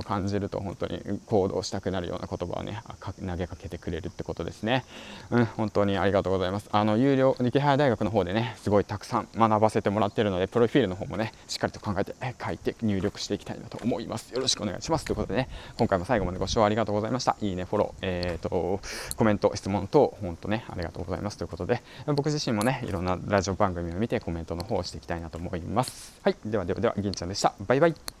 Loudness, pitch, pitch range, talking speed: -28 LUFS, 100 Hz, 90-115 Hz, 530 characters per minute